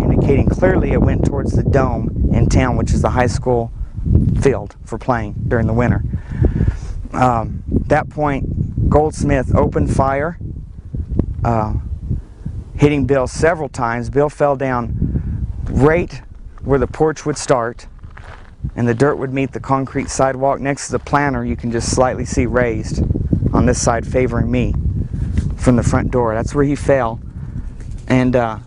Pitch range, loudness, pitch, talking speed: 110-135 Hz, -17 LUFS, 120 Hz, 155 wpm